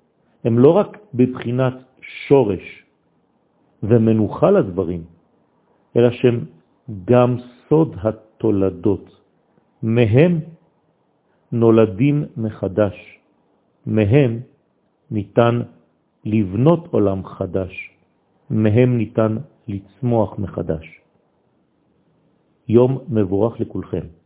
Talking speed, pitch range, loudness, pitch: 65 wpm, 100-125 Hz, -18 LUFS, 110 Hz